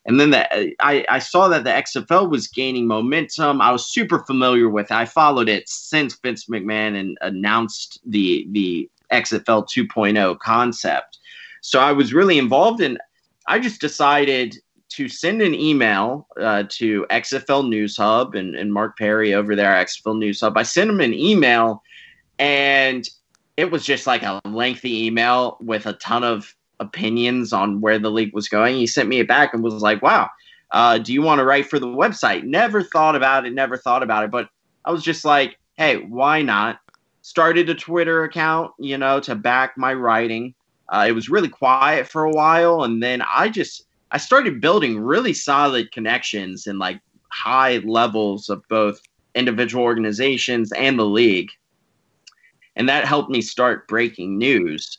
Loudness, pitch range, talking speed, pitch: -18 LUFS, 110-140 Hz, 180 wpm, 120 Hz